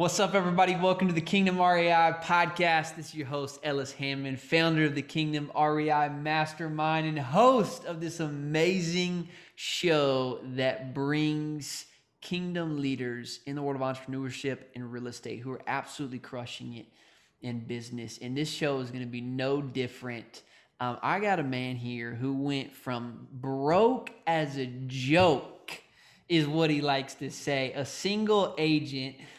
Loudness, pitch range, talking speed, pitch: -29 LUFS, 130-165 Hz, 155 wpm, 145 Hz